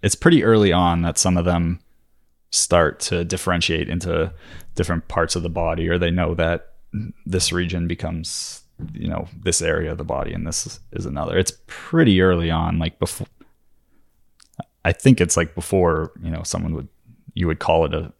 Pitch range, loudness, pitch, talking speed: 80-90 Hz, -20 LUFS, 85 Hz, 180 wpm